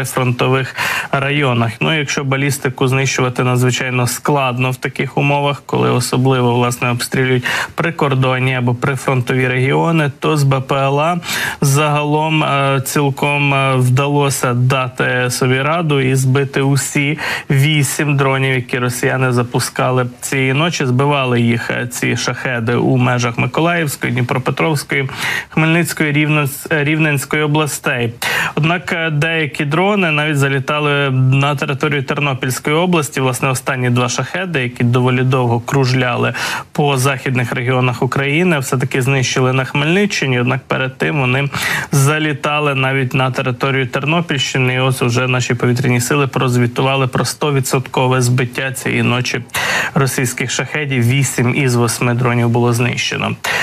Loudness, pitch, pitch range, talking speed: -15 LUFS, 135 Hz, 125-145 Hz, 115 wpm